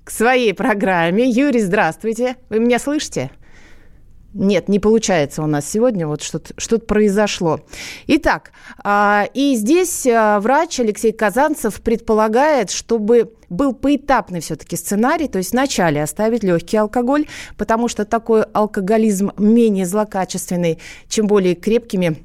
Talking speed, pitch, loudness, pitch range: 120 wpm, 215 Hz, -17 LUFS, 190-240 Hz